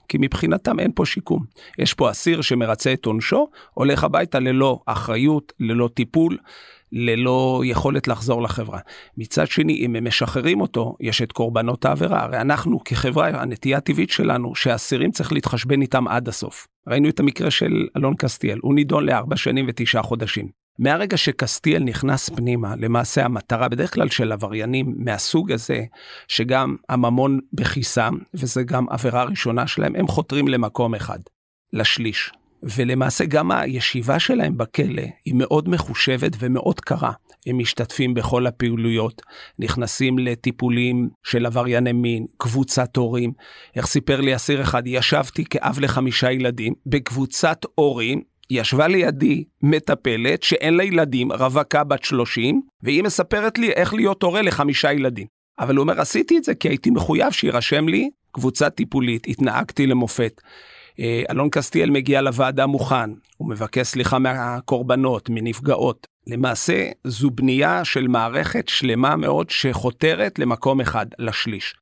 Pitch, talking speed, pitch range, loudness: 130 Hz, 140 wpm, 120-140 Hz, -20 LUFS